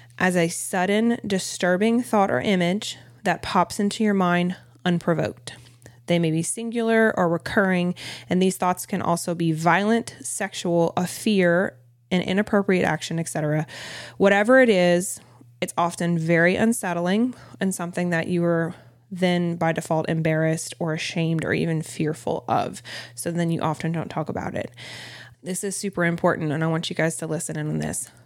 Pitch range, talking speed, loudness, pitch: 160-185 Hz, 165 wpm, -23 LUFS, 170 Hz